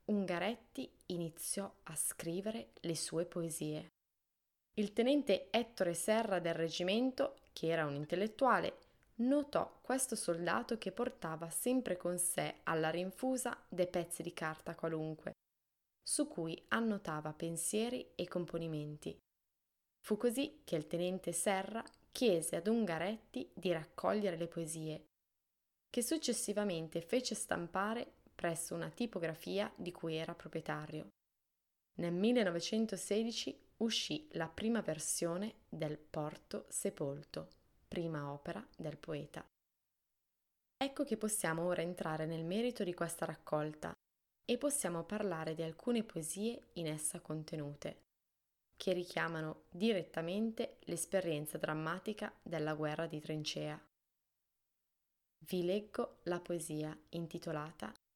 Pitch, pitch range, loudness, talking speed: 175 Hz, 160-215 Hz, -39 LUFS, 110 wpm